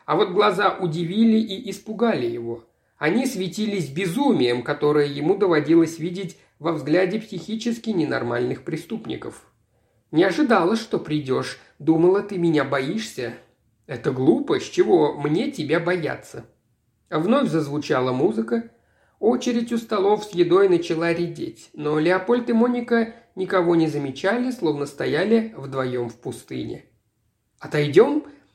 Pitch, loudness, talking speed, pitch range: 175 Hz, -22 LUFS, 120 wpm, 145-220 Hz